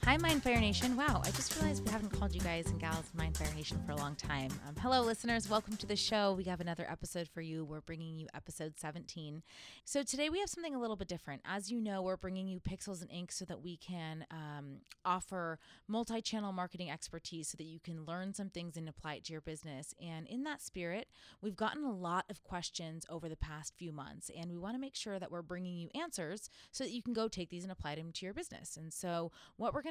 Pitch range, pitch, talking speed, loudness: 160-210 Hz, 175 Hz, 250 wpm, -40 LUFS